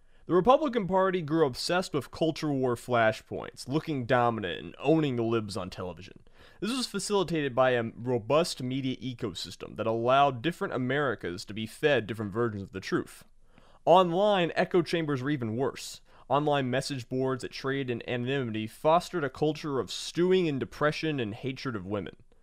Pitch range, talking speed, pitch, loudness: 115-160 Hz, 165 wpm, 135 Hz, -29 LUFS